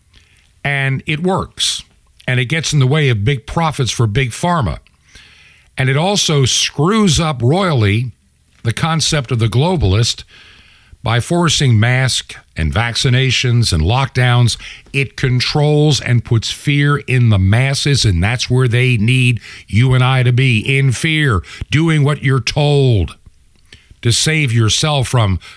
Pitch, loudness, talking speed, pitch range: 125 Hz, -14 LUFS, 145 wpm, 110-145 Hz